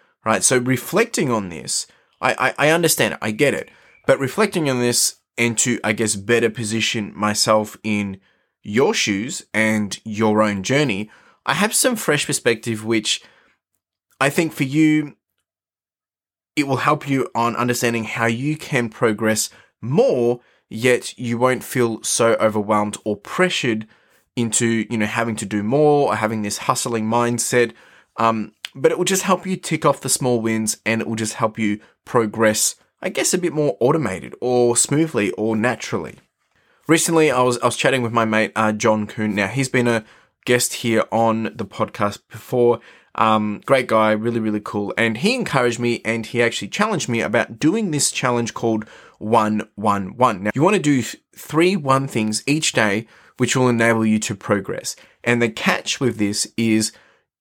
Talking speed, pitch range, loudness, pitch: 175 wpm, 110-135 Hz, -19 LUFS, 115 Hz